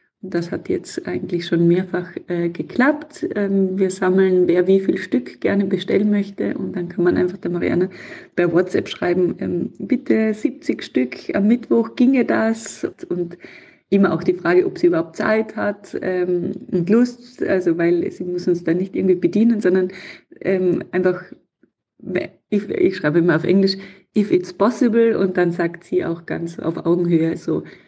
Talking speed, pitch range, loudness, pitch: 170 wpm, 175-220 Hz, -19 LUFS, 185 Hz